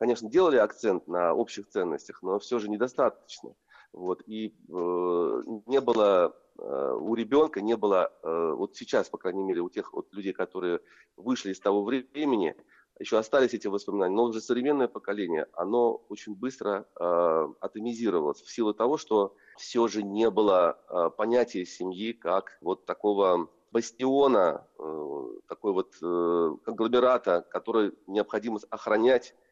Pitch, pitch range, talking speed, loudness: 115 Hz, 95-125 Hz, 145 wpm, -28 LUFS